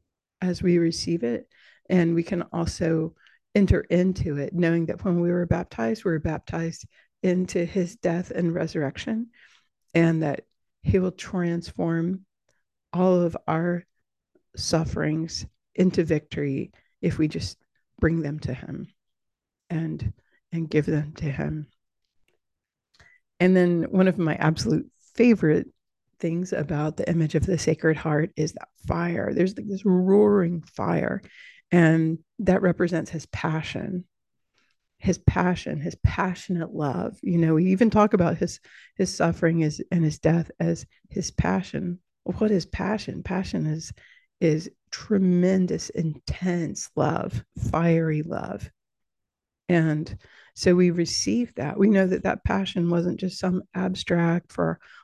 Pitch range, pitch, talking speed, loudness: 160-185 Hz, 170 Hz, 135 wpm, -25 LUFS